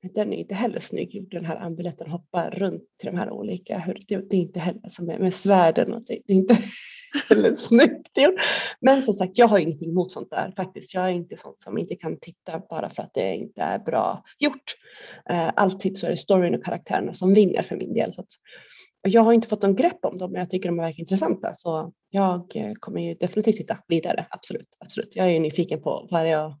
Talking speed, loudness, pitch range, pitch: 230 wpm, -23 LUFS, 175-215 Hz, 190 Hz